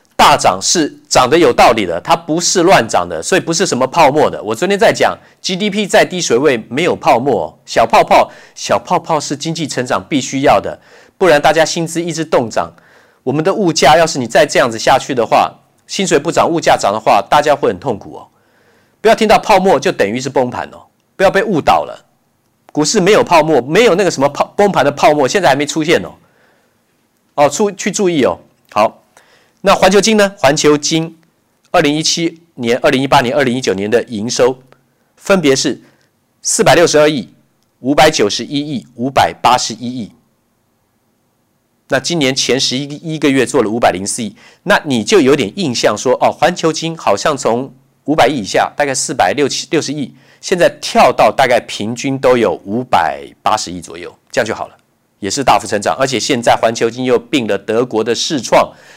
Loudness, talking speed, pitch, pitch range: -12 LUFS, 285 characters per minute, 150 Hz, 130-170 Hz